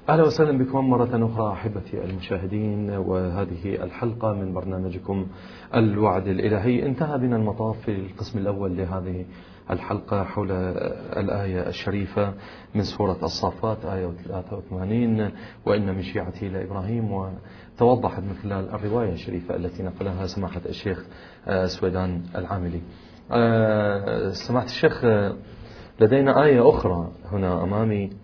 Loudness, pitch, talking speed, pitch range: -24 LUFS, 100 Hz, 105 wpm, 95-110 Hz